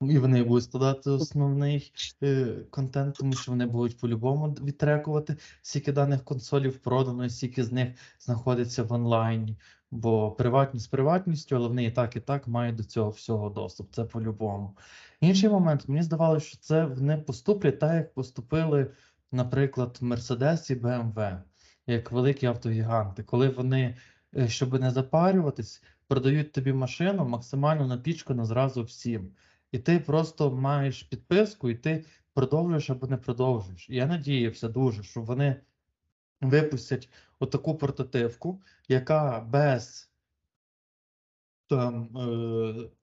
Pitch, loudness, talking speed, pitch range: 130 Hz, -28 LUFS, 130 wpm, 120-145 Hz